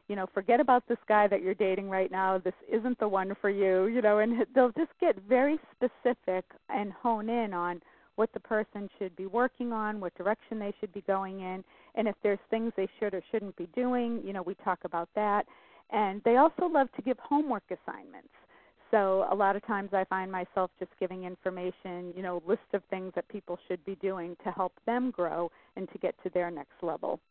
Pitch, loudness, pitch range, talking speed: 200 Hz, -31 LUFS, 185-230 Hz, 220 wpm